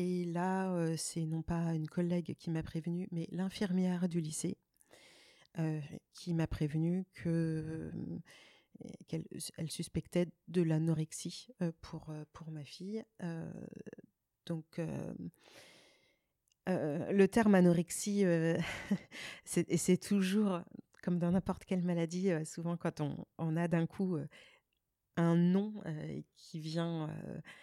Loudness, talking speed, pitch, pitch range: -36 LUFS, 135 wpm, 170 Hz, 160-185 Hz